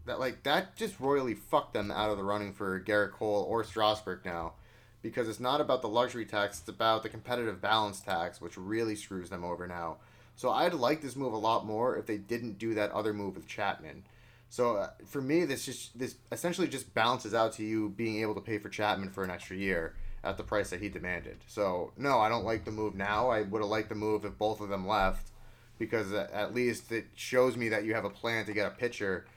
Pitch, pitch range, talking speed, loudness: 110 Hz, 100-120 Hz, 235 wpm, -33 LUFS